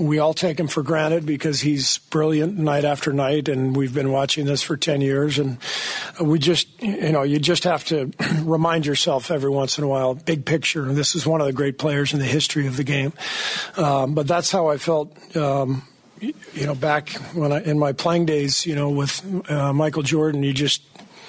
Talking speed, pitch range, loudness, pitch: 215 wpm, 140-165 Hz, -21 LUFS, 150 Hz